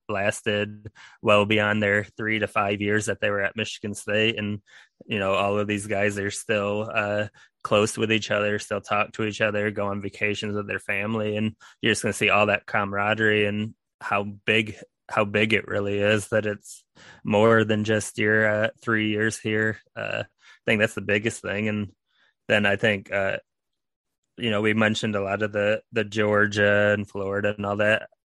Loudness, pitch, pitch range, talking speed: -24 LUFS, 105 Hz, 105-110 Hz, 195 wpm